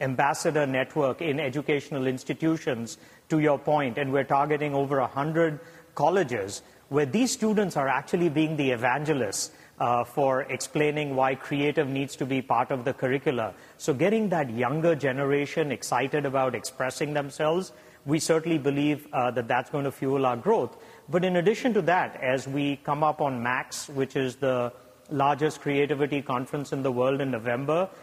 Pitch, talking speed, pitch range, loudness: 145 Hz, 165 wpm, 130-155 Hz, -27 LUFS